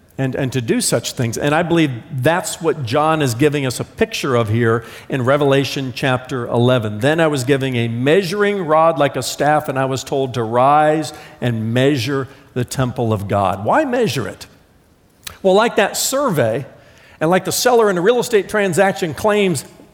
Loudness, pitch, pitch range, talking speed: -17 LUFS, 140 Hz, 125-165 Hz, 185 wpm